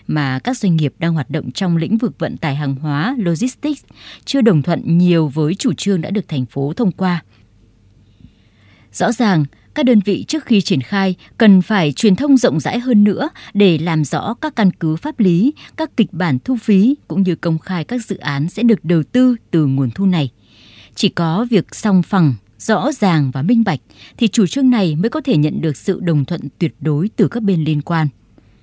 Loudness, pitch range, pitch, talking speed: -16 LUFS, 150-220 Hz, 180 Hz, 215 wpm